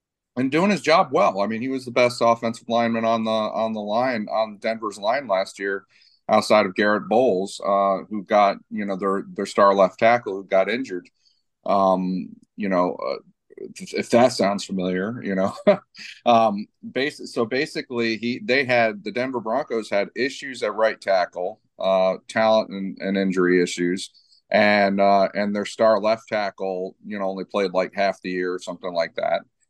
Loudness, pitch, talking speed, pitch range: -22 LUFS, 105 Hz, 180 wpm, 95-115 Hz